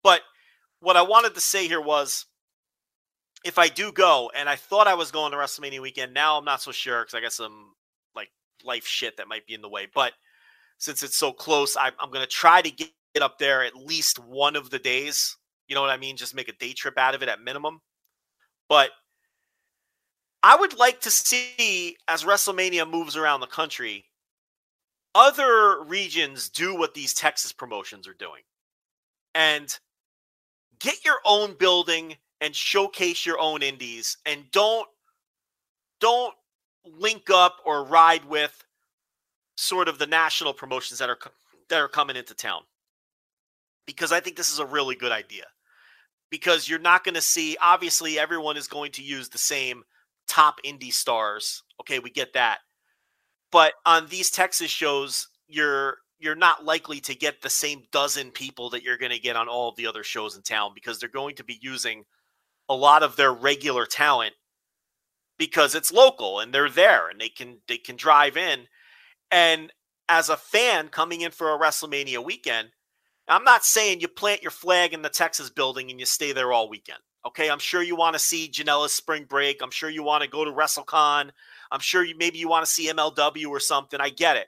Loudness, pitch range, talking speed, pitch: -22 LUFS, 140-180 Hz, 190 wpm, 155 Hz